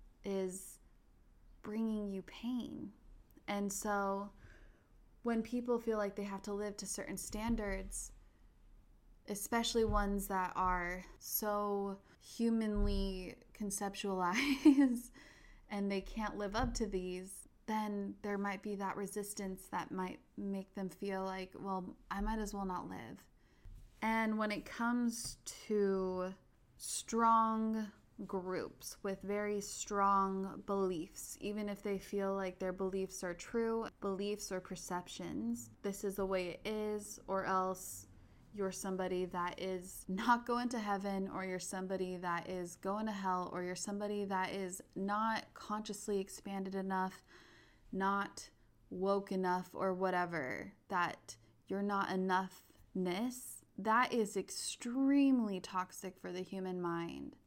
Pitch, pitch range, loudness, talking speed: 195 Hz, 185-210 Hz, -39 LUFS, 130 wpm